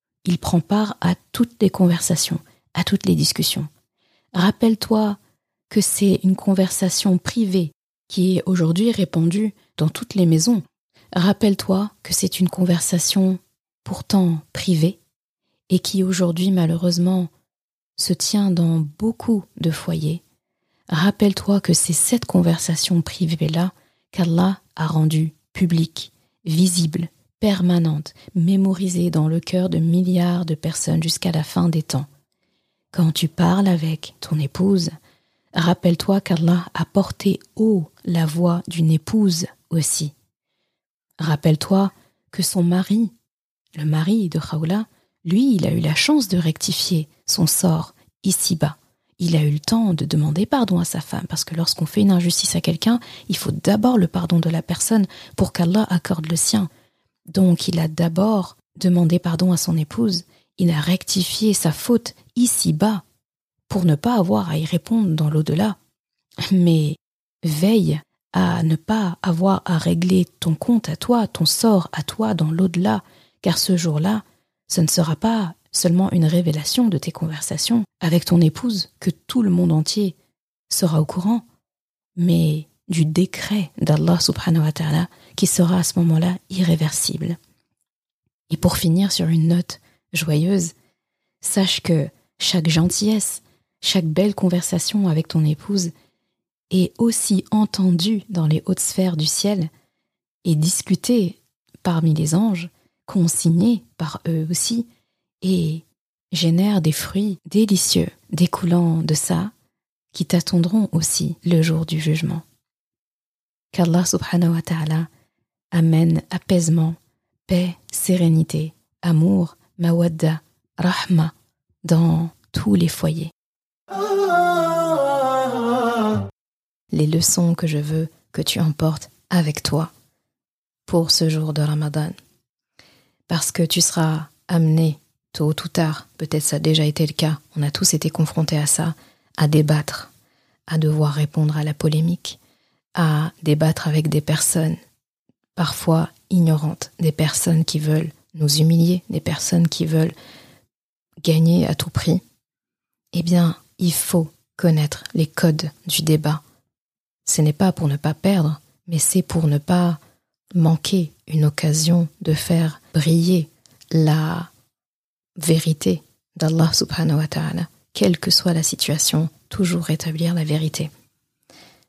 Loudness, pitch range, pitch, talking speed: -19 LUFS, 155-185 Hz, 170 Hz, 135 wpm